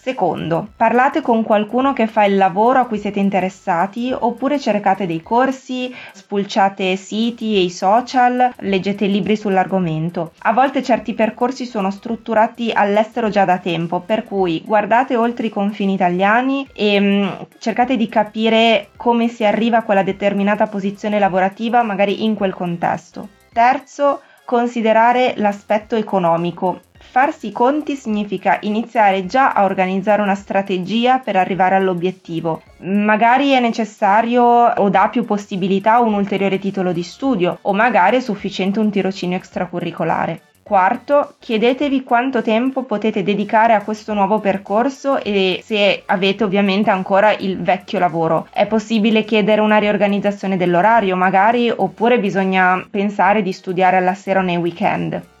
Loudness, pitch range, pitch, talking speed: -16 LUFS, 190-230 Hz, 210 Hz, 140 wpm